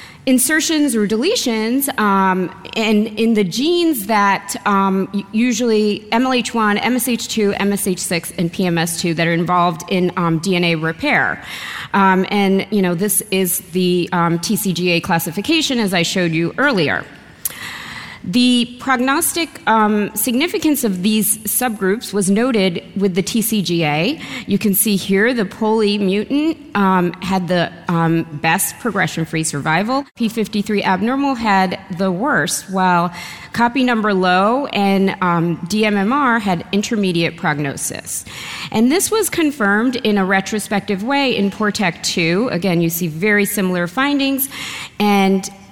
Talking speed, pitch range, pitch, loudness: 125 wpm, 180-230 Hz, 200 Hz, -17 LUFS